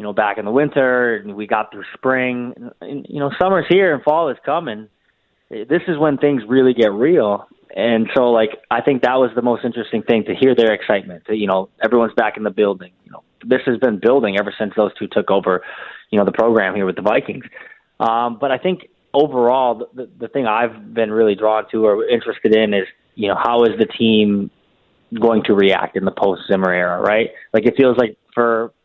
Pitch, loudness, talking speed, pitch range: 115 Hz, -17 LUFS, 225 wpm, 105-130 Hz